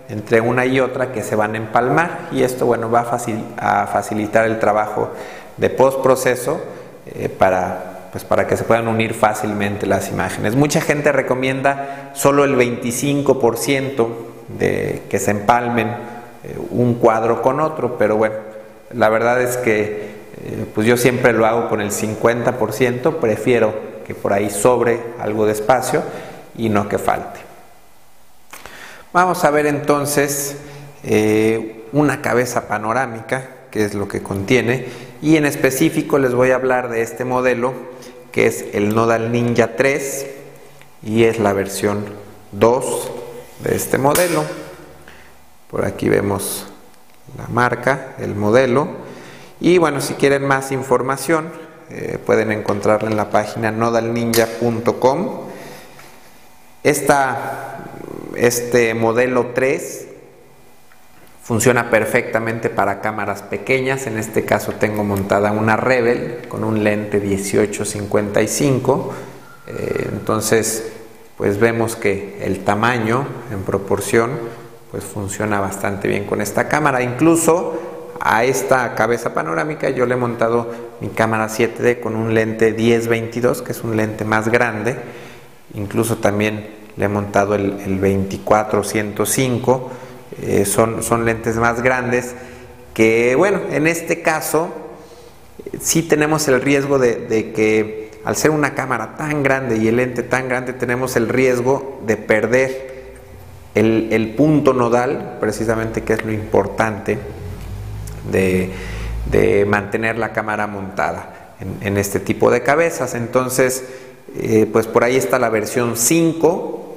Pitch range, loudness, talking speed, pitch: 110-130 Hz, -17 LUFS, 135 wpm, 115 Hz